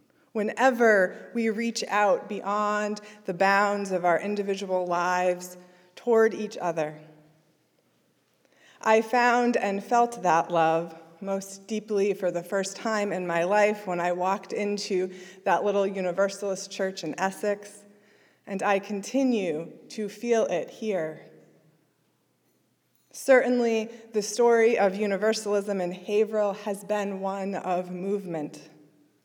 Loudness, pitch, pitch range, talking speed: -26 LUFS, 200 Hz, 180-215 Hz, 120 wpm